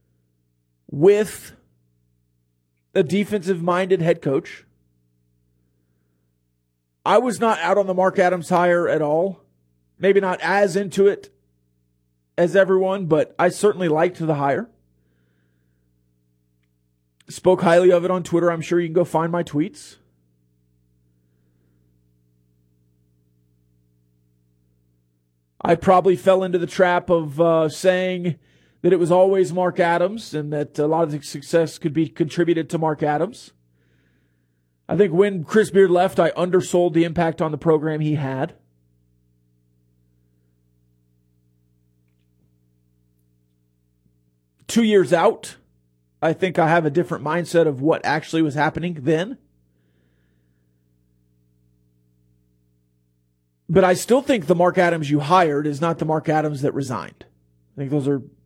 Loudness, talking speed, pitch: -19 LUFS, 125 wpm, 130 Hz